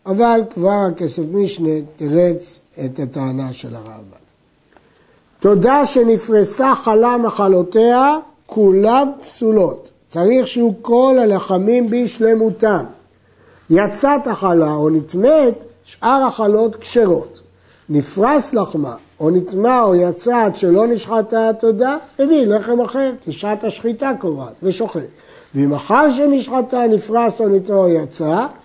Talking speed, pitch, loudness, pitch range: 105 wpm, 220 Hz, -15 LUFS, 175-240 Hz